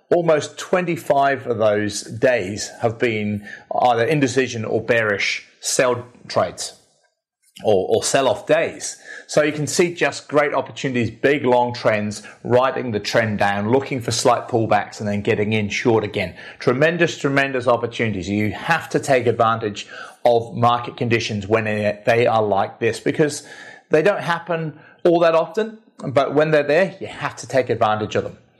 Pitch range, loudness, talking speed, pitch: 110-150 Hz, -20 LUFS, 160 wpm, 125 Hz